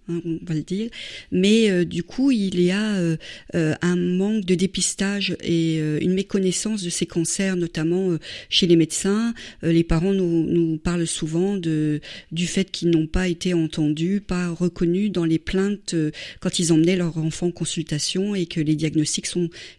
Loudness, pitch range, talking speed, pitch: -22 LUFS, 165-190 Hz, 190 wpm, 175 Hz